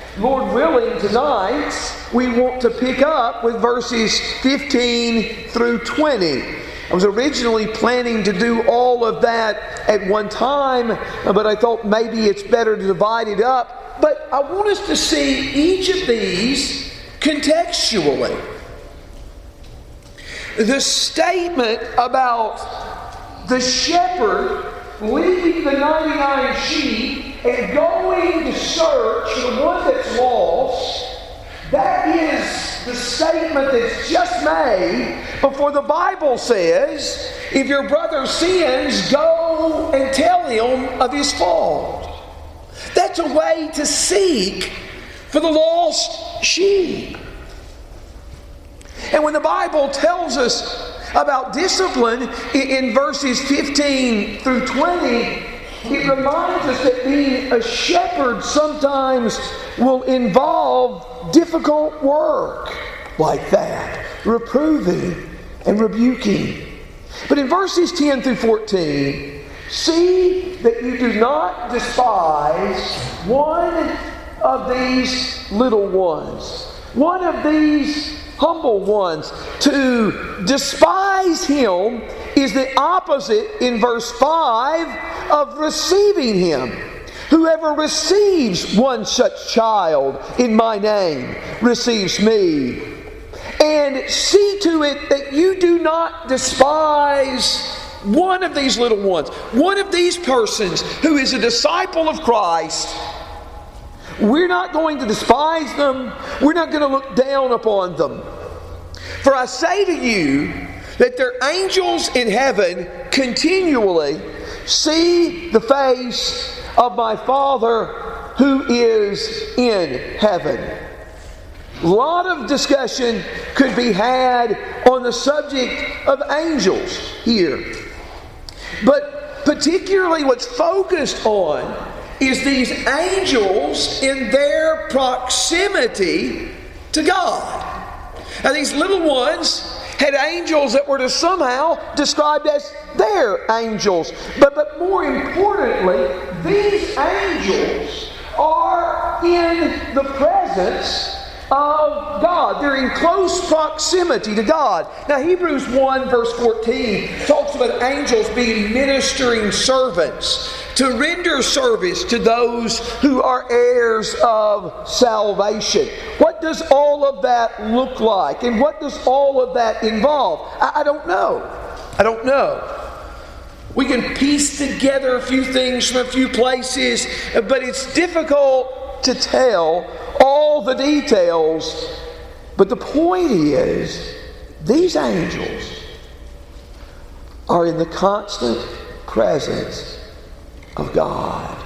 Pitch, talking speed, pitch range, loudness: 275 Hz, 110 wpm, 235-320 Hz, -17 LUFS